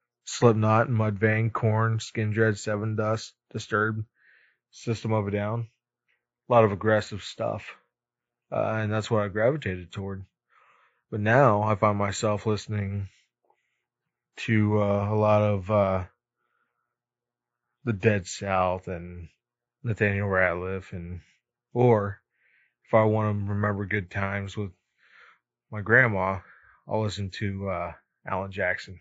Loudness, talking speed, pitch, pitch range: -26 LUFS, 130 wpm, 105 Hz, 100-115 Hz